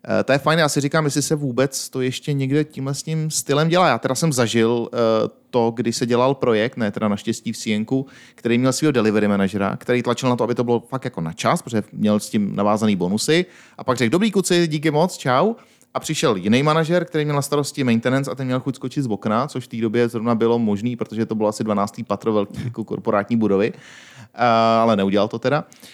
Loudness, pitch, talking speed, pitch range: -20 LUFS, 125 Hz, 225 wpm, 115-145 Hz